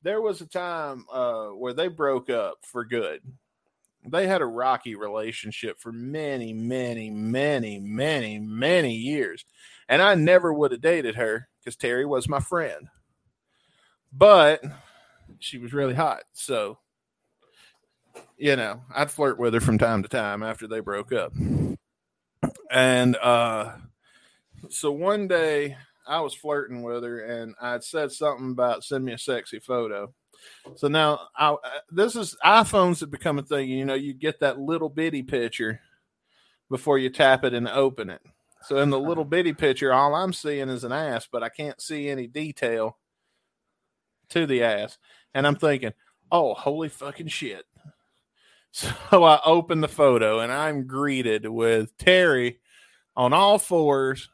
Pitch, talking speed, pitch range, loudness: 135 Hz, 155 wpm, 120-155 Hz, -24 LUFS